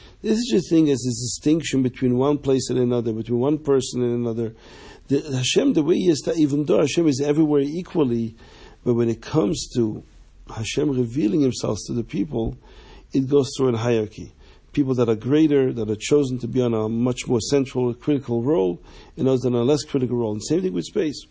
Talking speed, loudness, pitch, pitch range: 210 wpm, -22 LUFS, 130 Hz, 115-145 Hz